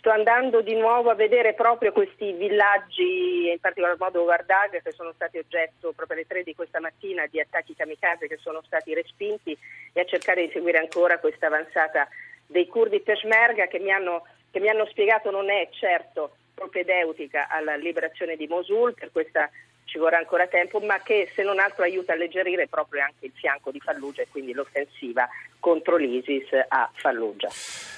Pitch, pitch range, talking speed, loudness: 185 Hz, 165-225 Hz, 175 wpm, -24 LUFS